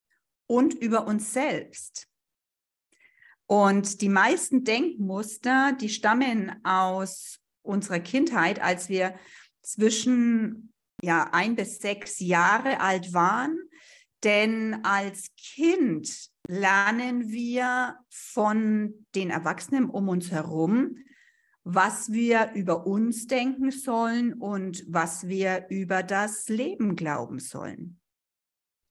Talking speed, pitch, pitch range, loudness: 100 wpm, 210 Hz, 185-245 Hz, -26 LUFS